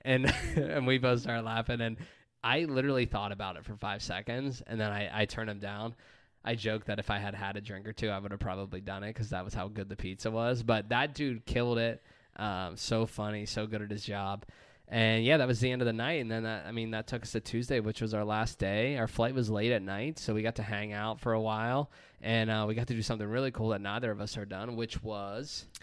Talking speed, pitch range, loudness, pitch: 270 wpm, 105-120 Hz, -33 LUFS, 110 Hz